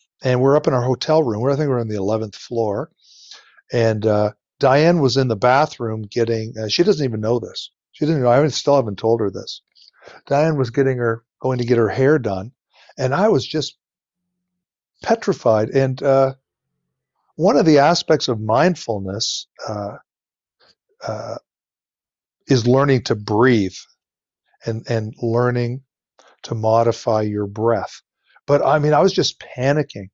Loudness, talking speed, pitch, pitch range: -18 LUFS, 165 wpm, 125 Hz, 115-145 Hz